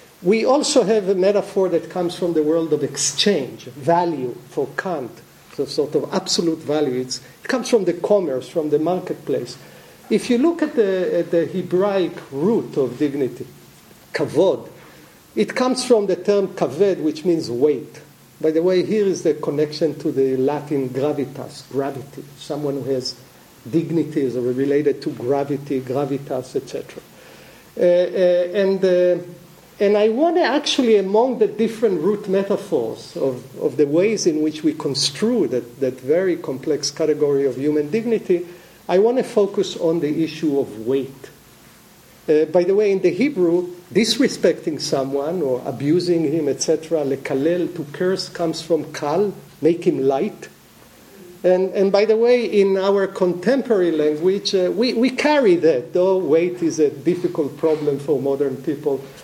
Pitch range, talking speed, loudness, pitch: 145-200 Hz, 160 wpm, -20 LUFS, 170 Hz